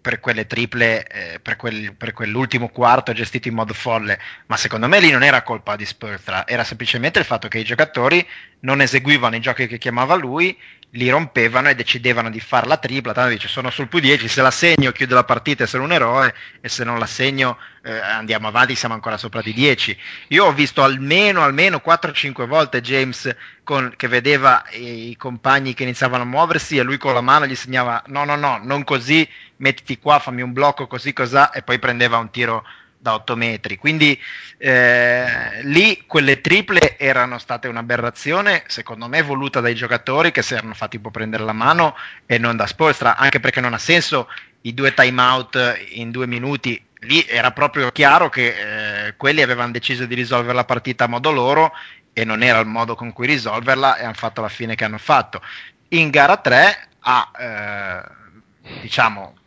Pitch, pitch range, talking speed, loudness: 125 Hz, 115-140 Hz, 195 wpm, -16 LUFS